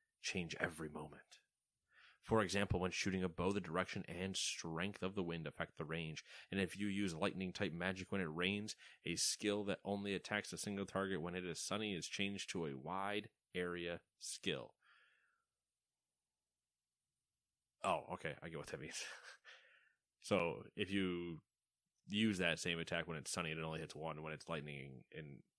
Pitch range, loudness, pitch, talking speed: 80-100 Hz, -43 LUFS, 90 Hz, 175 wpm